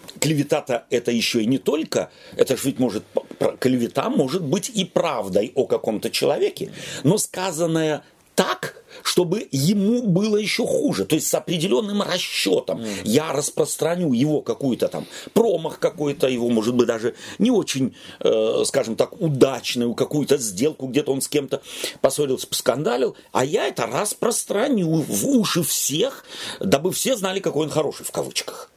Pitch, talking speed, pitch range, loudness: 175 Hz, 145 wpm, 145-210 Hz, -22 LUFS